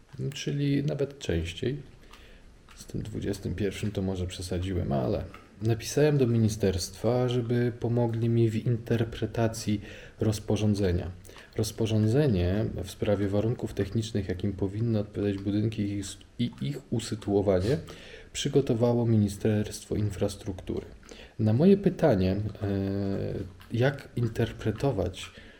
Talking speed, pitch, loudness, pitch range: 90 wpm, 110 Hz, -29 LUFS, 100-120 Hz